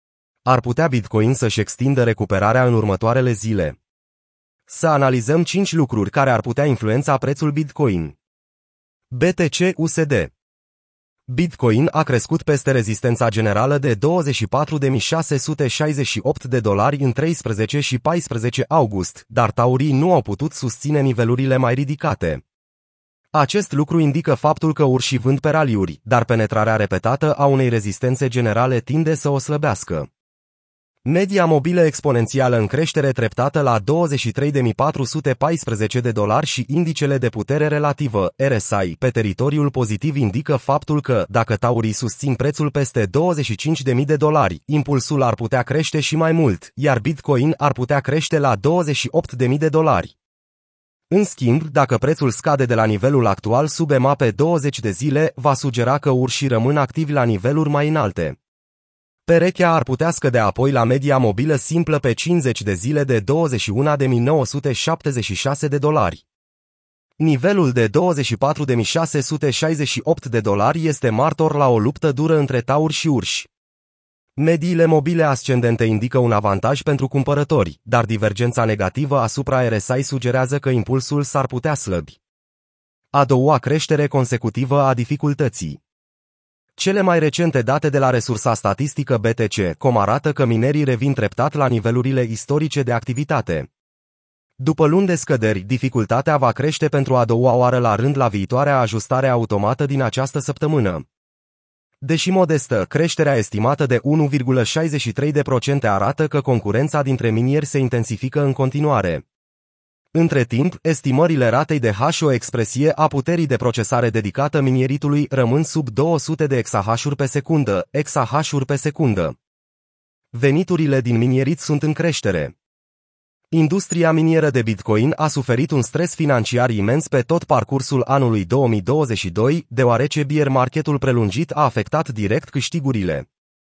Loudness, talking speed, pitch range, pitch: -18 LUFS, 135 wpm, 120-150 Hz, 135 Hz